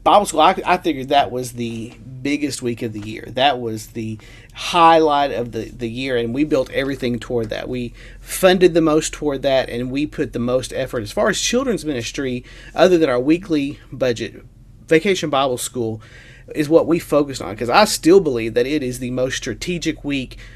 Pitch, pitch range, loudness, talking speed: 130 Hz, 120-155 Hz, -19 LUFS, 200 wpm